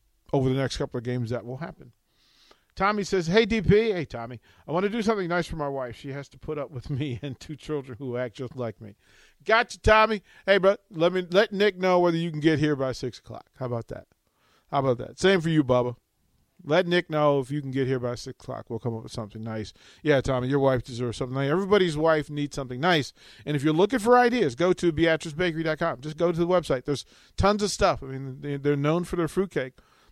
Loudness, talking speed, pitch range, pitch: -25 LUFS, 240 wpm, 125-180 Hz, 145 Hz